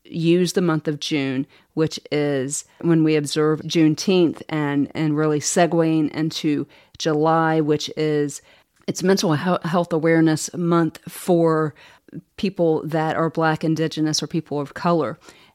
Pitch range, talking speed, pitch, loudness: 150-165 Hz, 130 wpm, 160 Hz, -21 LUFS